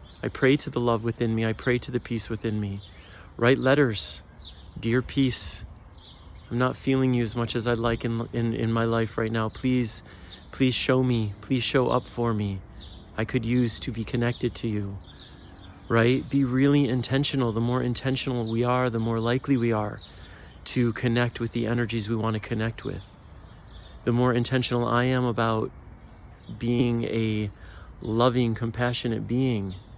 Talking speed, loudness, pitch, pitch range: 170 wpm, -26 LUFS, 115 Hz, 105-125 Hz